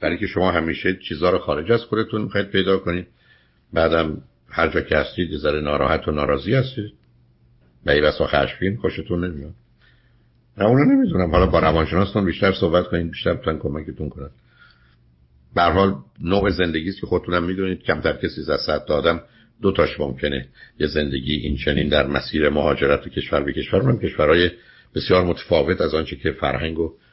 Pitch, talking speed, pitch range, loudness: 85 Hz, 170 wpm, 70-95 Hz, -21 LUFS